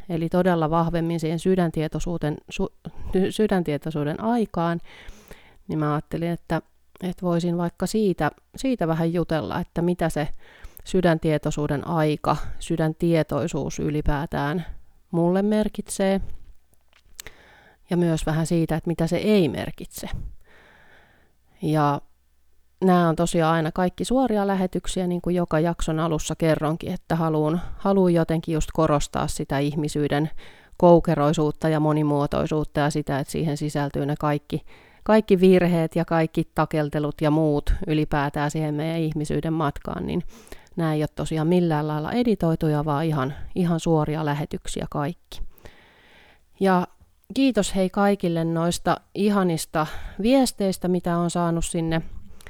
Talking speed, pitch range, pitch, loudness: 120 wpm, 150-180 Hz, 165 Hz, -24 LUFS